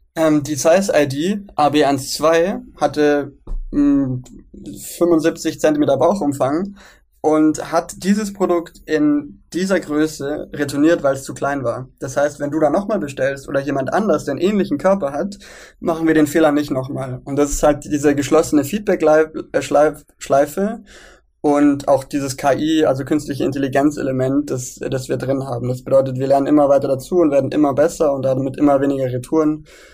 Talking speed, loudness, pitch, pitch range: 160 wpm, -18 LUFS, 145 Hz, 140-160 Hz